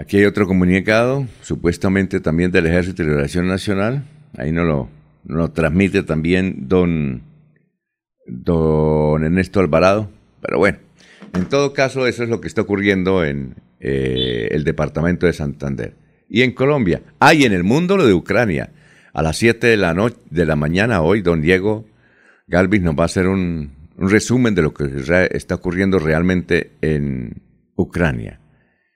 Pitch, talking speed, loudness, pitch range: 90 Hz, 160 wpm, -17 LUFS, 80-105 Hz